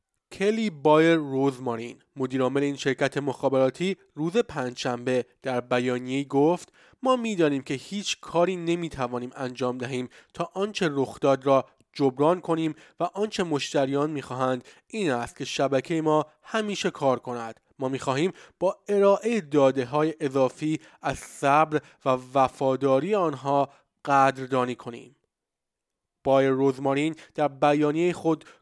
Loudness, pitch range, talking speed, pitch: -26 LUFS, 130-165 Hz, 120 wpm, 140 Hz